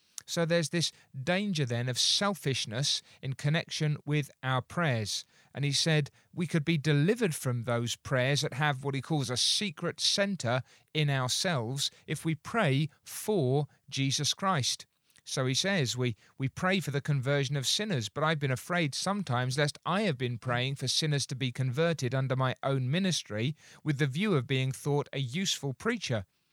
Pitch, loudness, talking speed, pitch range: 145 Hz, -30 LUFS, 175 wpm, 130-165 Hz